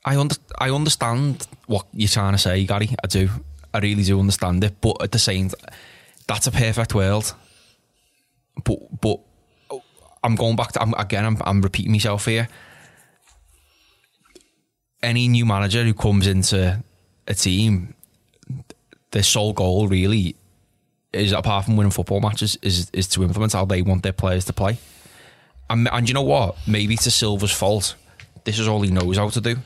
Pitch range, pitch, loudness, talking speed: 95-115 Hz, 105 Hz, -20 LUFS, 170 wpm